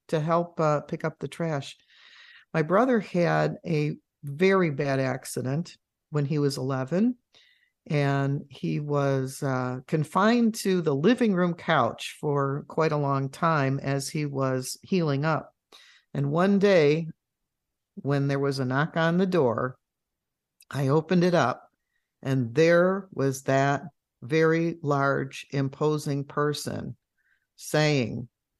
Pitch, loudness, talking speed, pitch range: 150 Hz, -26 LUFS, 130 wpm, 135-170 Hz